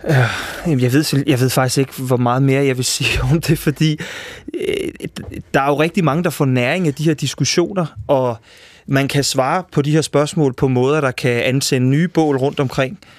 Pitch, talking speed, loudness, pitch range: 140 Hz, 200 wpm, -17 LUFS, 130-160 Hz